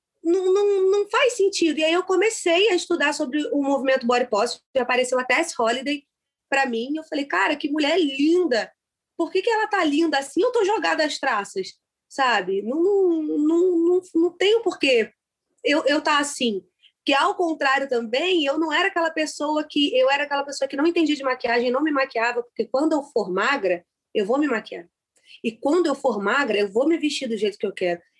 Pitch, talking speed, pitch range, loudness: 295 Hz, 215 wpm, 255-340 Hz, -22 LUFS